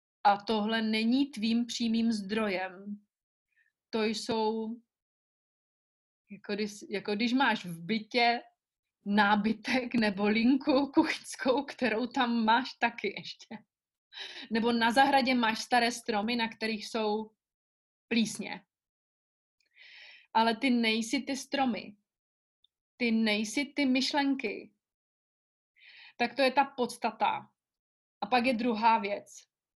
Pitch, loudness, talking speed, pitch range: 230 Hz, -30 LUFS, 105 wpm, 215-260 Hz